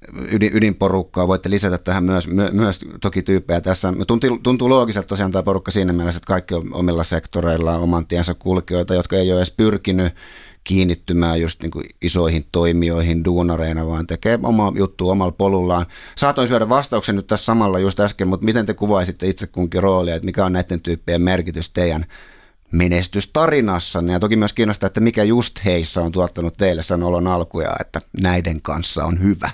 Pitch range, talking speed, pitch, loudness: 85-100 Hz, 175 wpm, 90 Hz, -18 LUFS